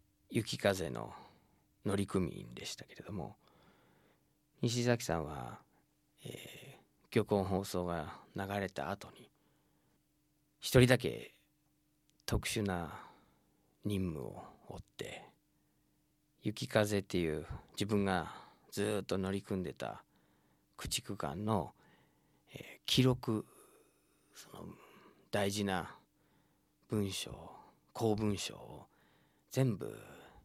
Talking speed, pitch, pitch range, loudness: 160 characters per minute, 105 Hz, 95-130 Hz, -37 LUFS